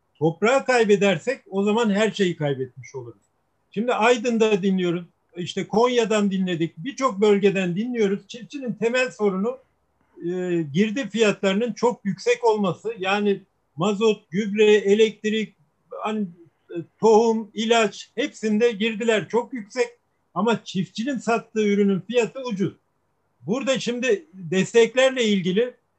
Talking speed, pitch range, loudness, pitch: 110 wpm, 190-235 Hz, -22 LUFS, 210 Hz